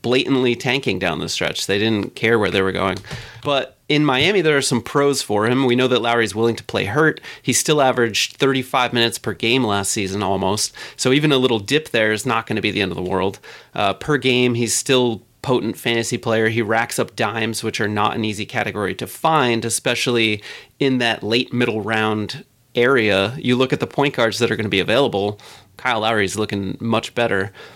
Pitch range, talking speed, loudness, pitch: 105-130 Hz, 210 wpm, -19 LUFS, 115 Hz